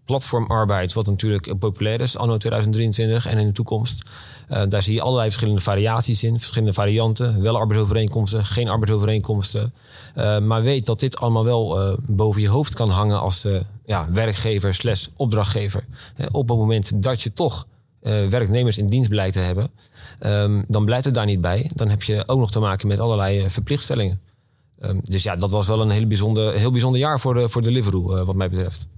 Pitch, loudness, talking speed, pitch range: 110 Hz, -20 LUFS, 200 wpm, 100-120 Hz